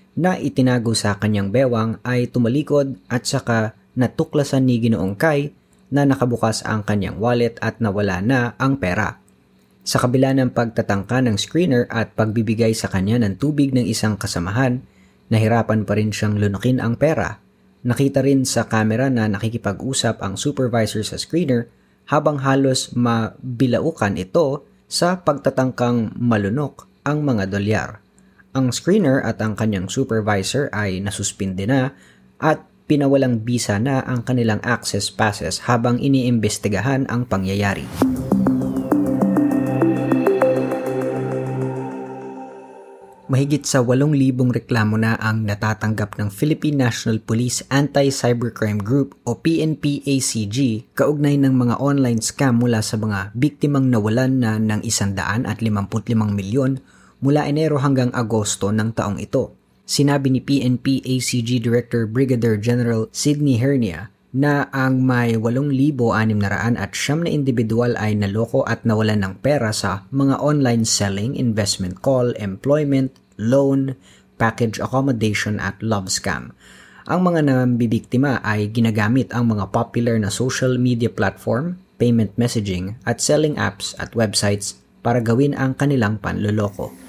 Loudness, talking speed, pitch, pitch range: -19 LUFS, 125 wpm, 120 Hz, 105-135 Hz